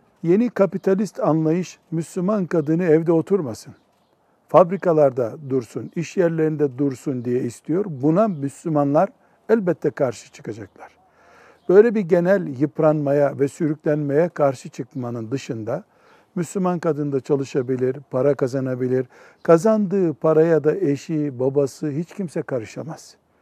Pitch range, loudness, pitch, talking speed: 140-180 Hz, -21 LUFS, 155 Hz, 110 wpm